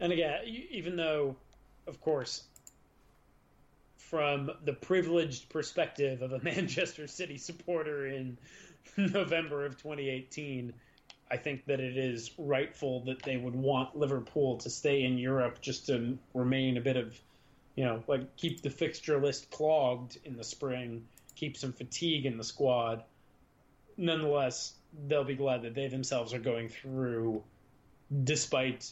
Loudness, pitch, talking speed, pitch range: -34 LUFS, 135 Hz, 140 wpm, 125-150 Hz